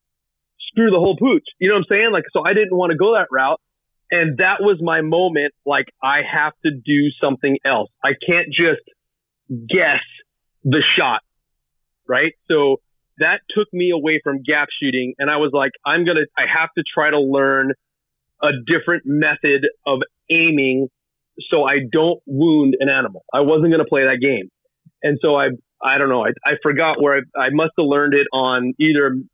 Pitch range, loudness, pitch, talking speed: 140-170 Hz, -17 LUFS, 150 Hz, 190 wpm